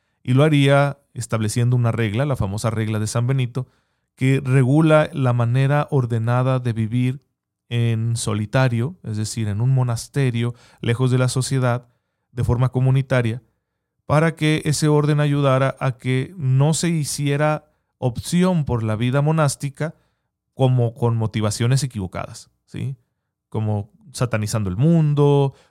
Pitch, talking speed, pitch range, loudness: 130 Hz, 135 wpm, 115-140 Hz, -20 LUFS